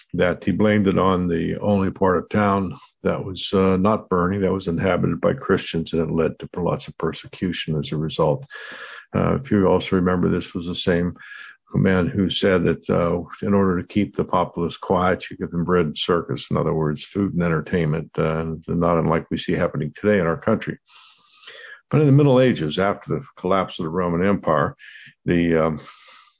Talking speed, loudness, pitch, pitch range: 195 wpm, -21 LUFS, 90 Hz, 80-100 Hz